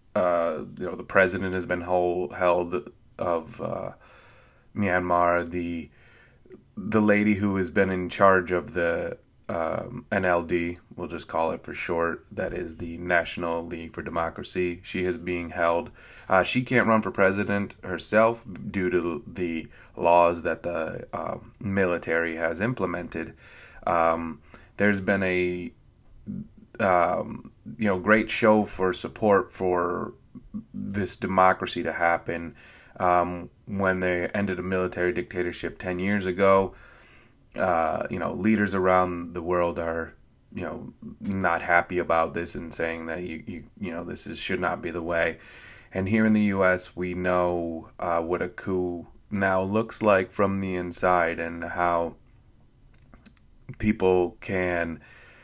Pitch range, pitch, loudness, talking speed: 85-100 Hz, 90 Hz, -26 LUFS, 145 wpm